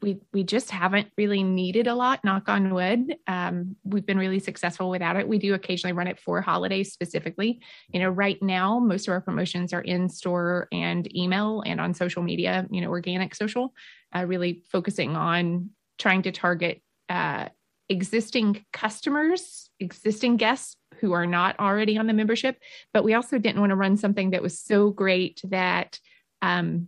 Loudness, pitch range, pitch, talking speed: -25 LUFS, 180-215 Hz, 195 Hz, 180 wpm